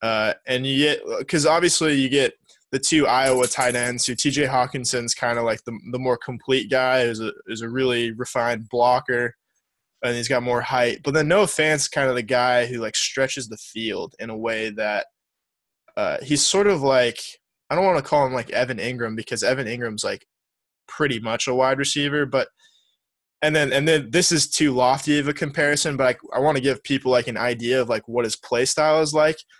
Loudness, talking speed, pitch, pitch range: -21 LUFS, 215 wpm, 130 Hz, 120-150 Hz